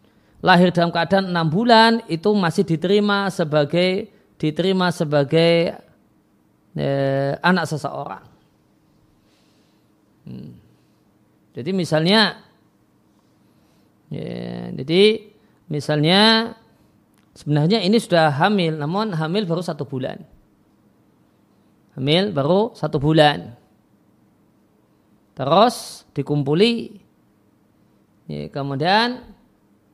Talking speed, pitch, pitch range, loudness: 75 wpm, 160 Hz, 130-195 Hz, -19 LUFS